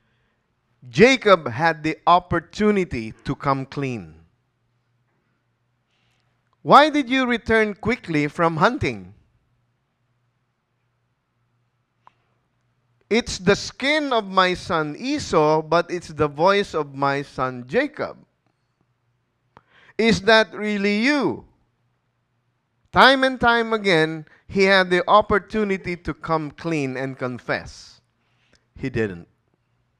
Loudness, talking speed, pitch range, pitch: -20 LUFS, 95 wpm, 120-200 Hz, 155 Hz